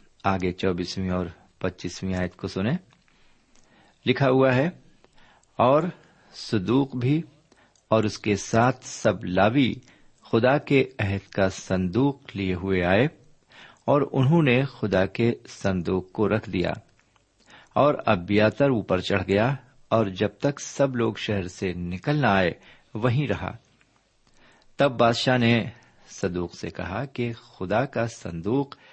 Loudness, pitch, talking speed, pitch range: -24 LUFS, 110 Hz, 135 wpm, 95-130 Hz